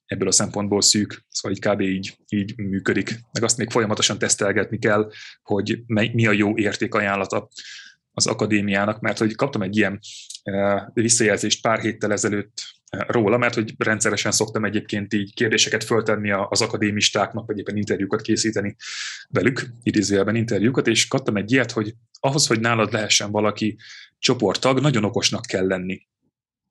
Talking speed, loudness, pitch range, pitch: 150 wpm, -21 LUFS, 100-115 Hz, 105 Hz